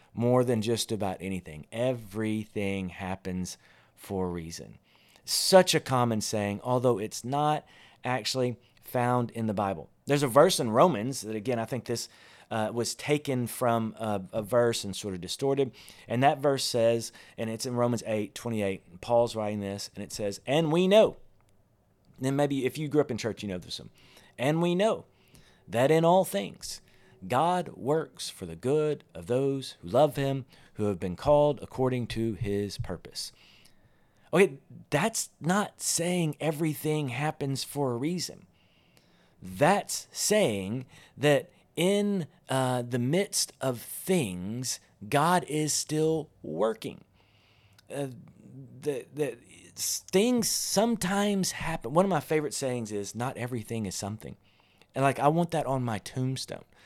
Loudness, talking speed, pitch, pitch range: -29 LUFS, 155 wpm, 125 Hz, 105-145 Hz